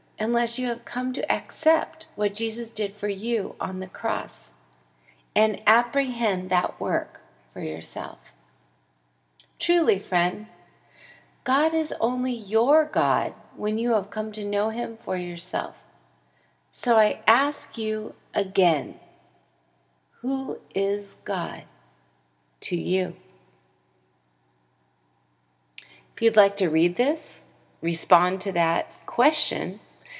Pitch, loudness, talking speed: 200 Hz, -25 LUFS, 110 wpm